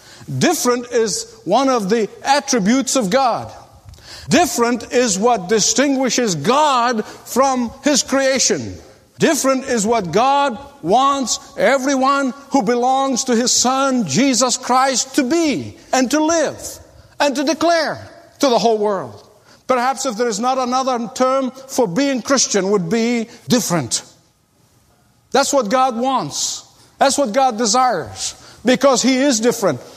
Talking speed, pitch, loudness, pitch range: 135 wpm, 255 Hz, -16 LUFS, 235-275 Hz